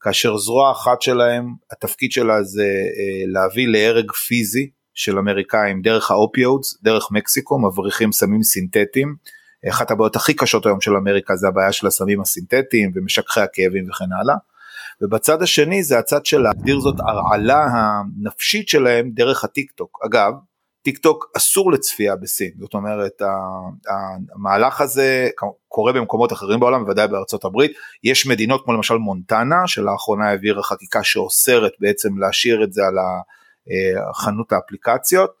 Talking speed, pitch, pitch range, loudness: 140 wpm, 110 Hz, 100-135 Hz, -17 LUFS